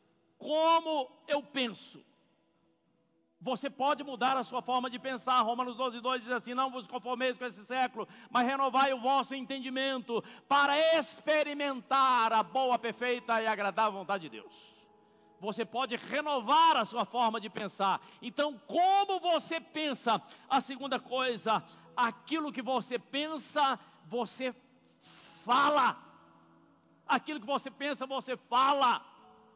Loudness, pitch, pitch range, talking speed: -31 LUFS, 255 Hz, 230-275 Hz, 130 wpm